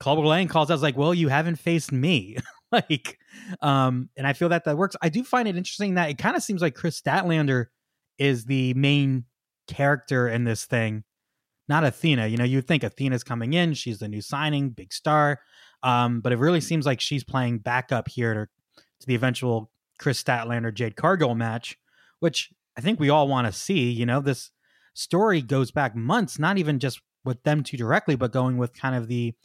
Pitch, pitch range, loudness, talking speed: 135 Hz, 125-155 Hz, -24 LUFS, 200 wpm